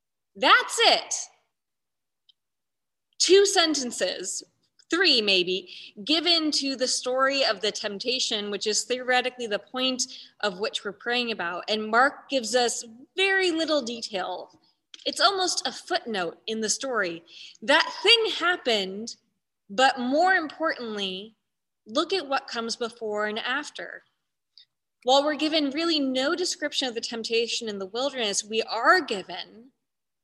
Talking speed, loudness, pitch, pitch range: 130 wpm, -24 LUFS, 250 Hz, 215-305 Hz